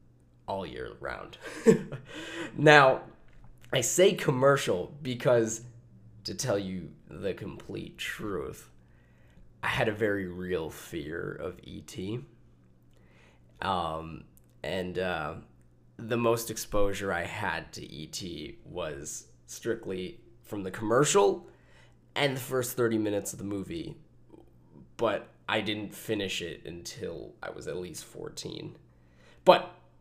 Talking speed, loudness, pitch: 115 wpm, -30 LUFS, 100 Hz